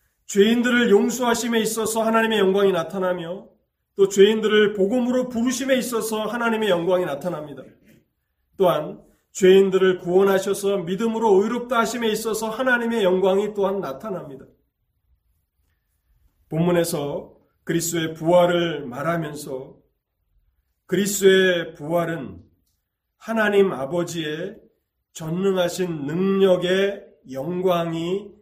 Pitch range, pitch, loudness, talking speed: 165-215 Hz, 190 Hz, -21 LUFS, 275 characters per minute